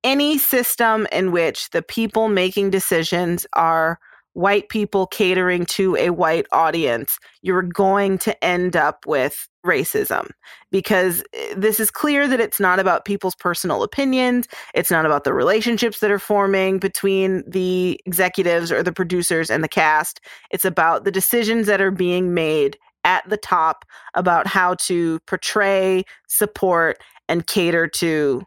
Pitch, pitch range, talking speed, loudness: 190 Hz, 180-215 Hz, 150 wpm, -19 LUFS